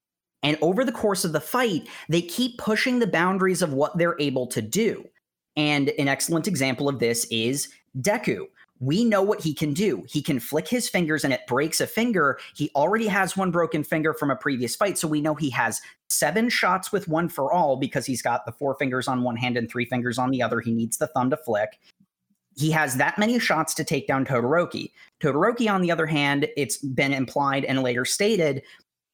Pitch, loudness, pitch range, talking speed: 150 Hz, -24 LUFS, 135-180 Hz, 215 wpm